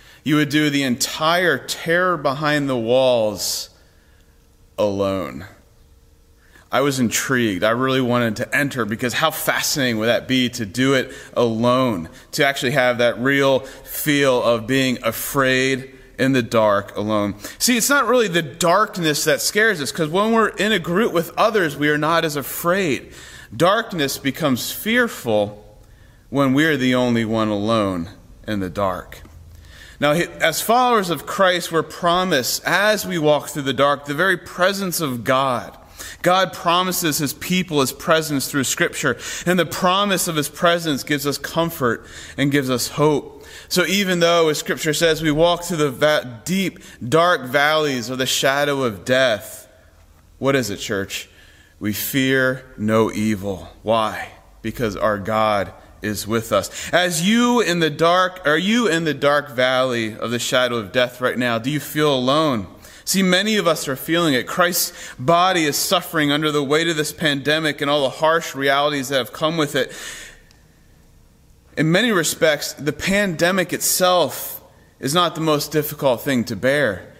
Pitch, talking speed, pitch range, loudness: 140 Hz, 165 wpm, 115-165 Hz, -19 LUFS